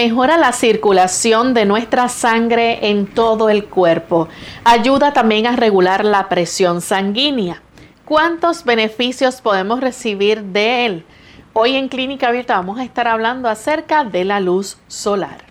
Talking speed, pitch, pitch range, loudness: 140 wpm, 225 Hz, 200-250 Hz, -15 LUFS